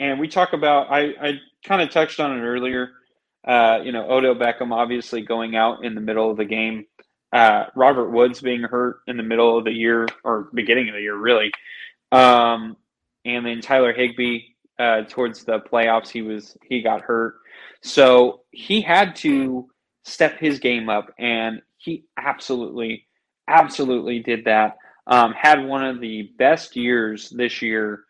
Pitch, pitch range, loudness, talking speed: 120 Hz, 115-130 Hz, -19 LUFS, 170 wpm